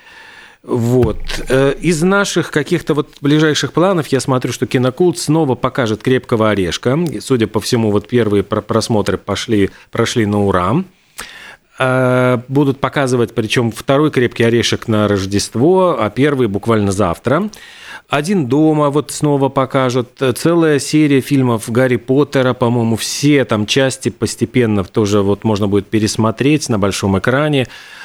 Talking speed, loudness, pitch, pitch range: 130 wpm, -15 LUFS, 125 Hz, 110-145 Hz